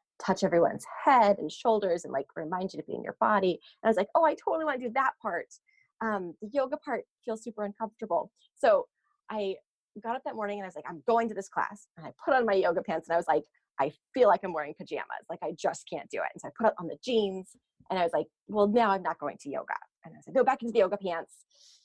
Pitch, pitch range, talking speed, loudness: 210 Hz, 180-250 Hz, 270 wpm, -30 LUFS